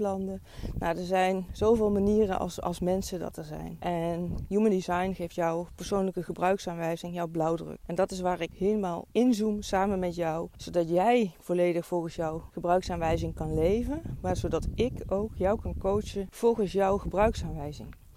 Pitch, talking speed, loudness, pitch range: 180 Hz, 160 wpm, -29 LUFS, 170-200 Hz